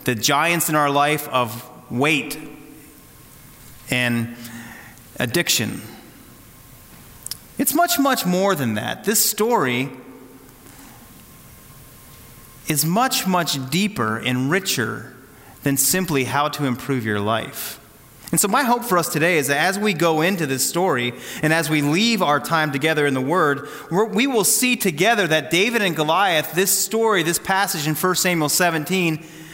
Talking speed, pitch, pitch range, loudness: 145 wpm, 150 Hz, 130-185 Hz, -19 LUFS